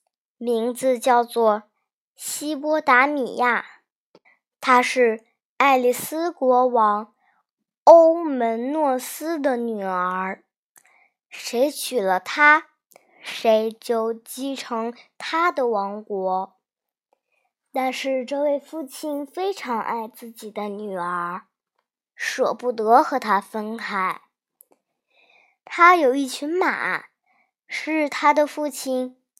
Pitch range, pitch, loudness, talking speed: 225-295 Hz, 255 Hz, -21 LUFS, 135 characters per minute